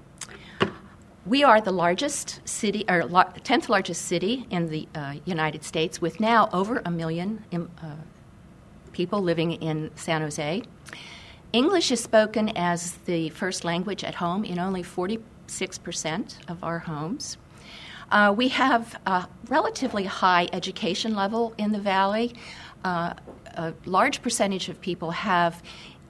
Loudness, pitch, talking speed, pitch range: -25 LUFS, 180 Hz, 135 wpm, 170-215 Hz